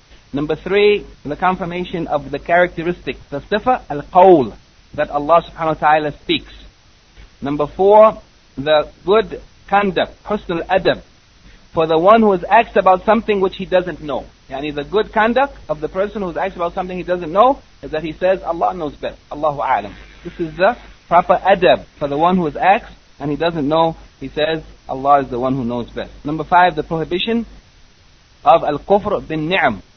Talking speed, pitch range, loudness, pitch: 190 wpm, 150-195 Hz, -16 LUFS, 170 Hz